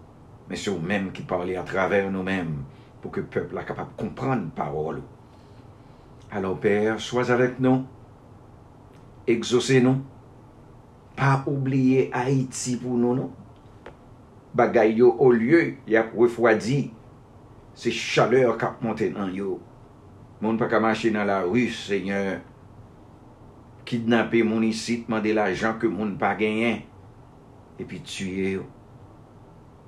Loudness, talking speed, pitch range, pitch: -24 LUFS, 130 wpm, 105-125 Hz, 115 Hz